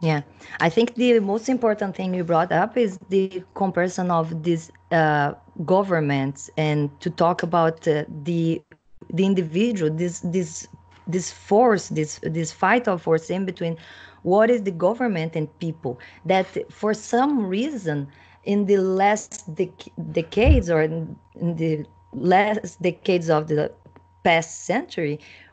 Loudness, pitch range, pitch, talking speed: -22 LUFS, 160-195 Hz, 175 Hz, 145 wpm